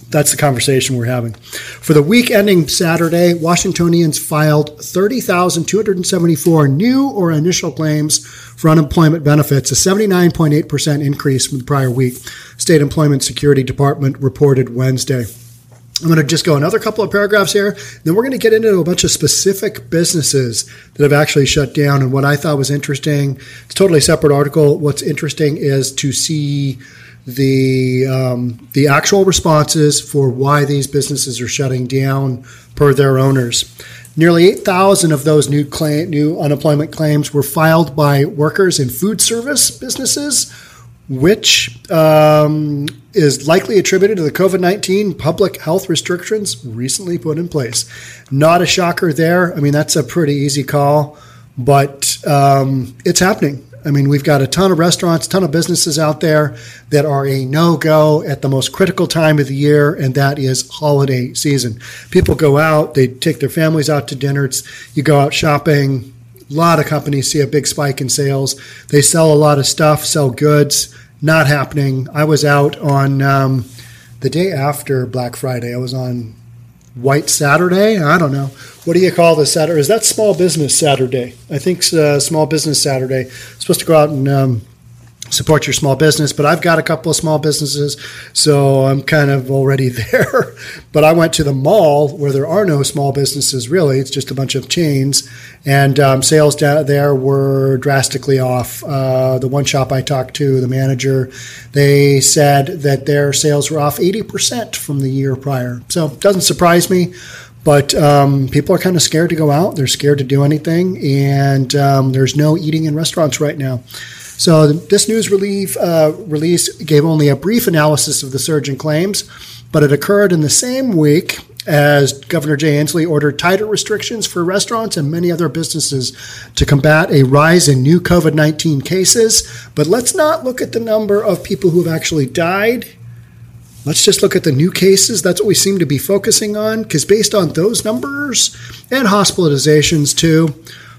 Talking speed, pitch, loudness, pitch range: 180 wpm, 150 Hz, -13 LUFS, 135-170 Hz